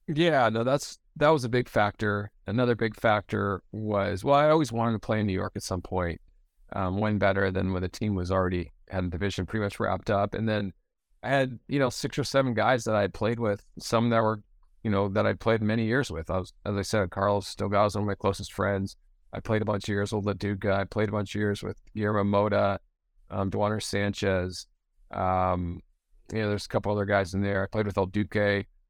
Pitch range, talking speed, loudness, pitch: 95-110 Hz, 235 wpm, -28 LUFS, 100 Hz